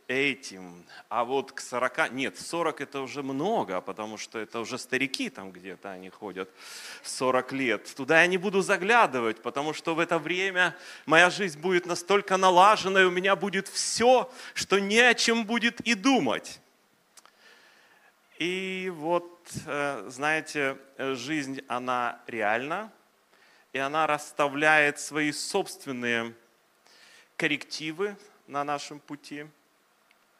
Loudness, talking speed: -26 LUFS, 125 wpm